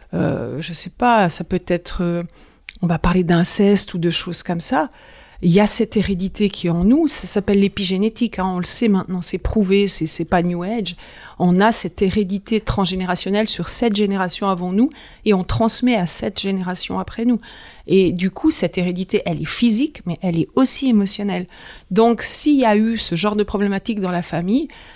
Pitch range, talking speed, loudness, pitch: 180-215 Hz, 200 wpm, -18 LUFS, 195 Hz